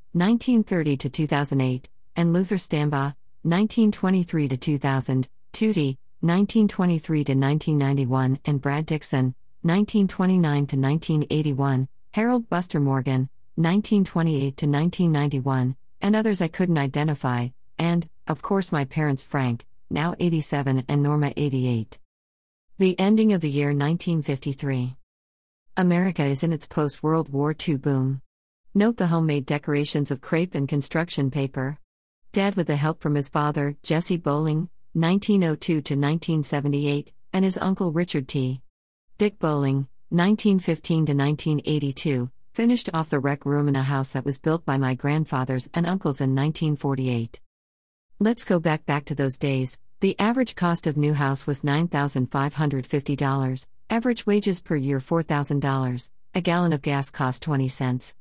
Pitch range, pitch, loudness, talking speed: 135-170 Hz, 150 Hz, -24 LUFS, 130 wpm